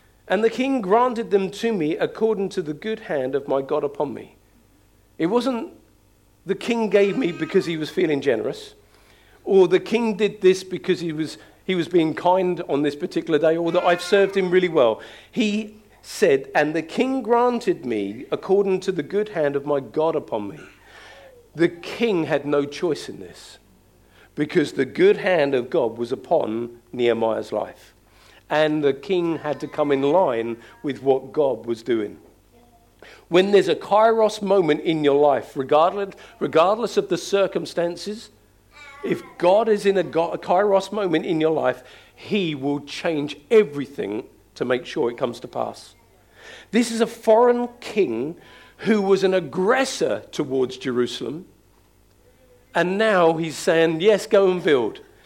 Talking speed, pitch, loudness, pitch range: 165 wpm, 180 Hz, -21 LUFS, 150-215 Hz